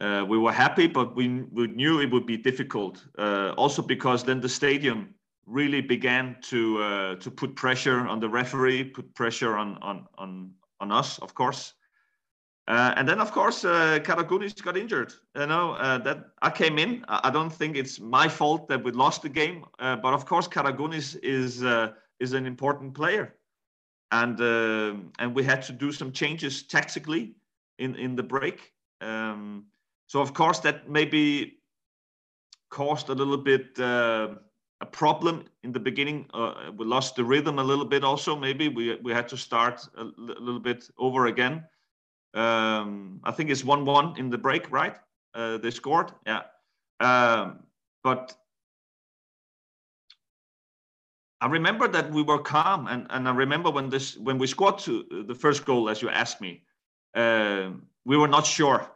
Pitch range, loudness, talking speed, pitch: 115-145 Hz, -26 LUFS, 175 wpm, 130 Hz